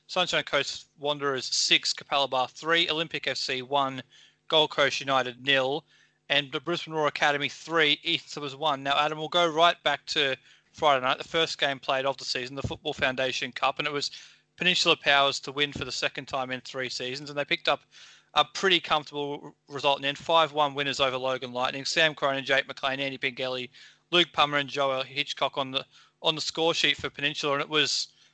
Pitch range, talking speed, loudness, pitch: 135-155 Hz, 200 wpm, -26 LUFS, 145 Hz